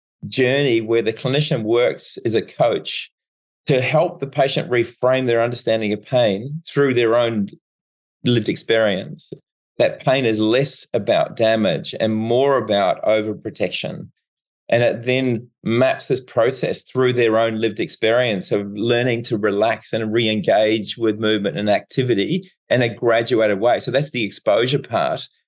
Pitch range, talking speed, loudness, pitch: 110-130 Hz, 150 wpm, -19 LUFS, 115 Hz